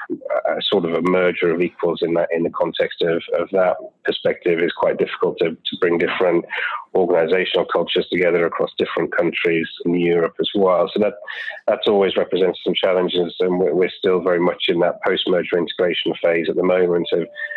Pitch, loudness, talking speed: 320 Hz, -19 LUFS, 185 wpm